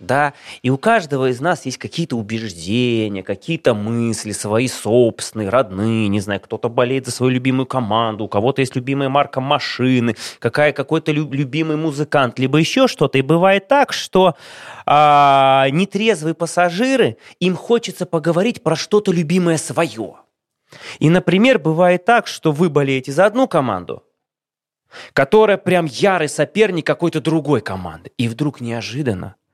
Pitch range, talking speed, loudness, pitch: 125-175 Hz, 140 wpm, -17 LUFS, 145 Hz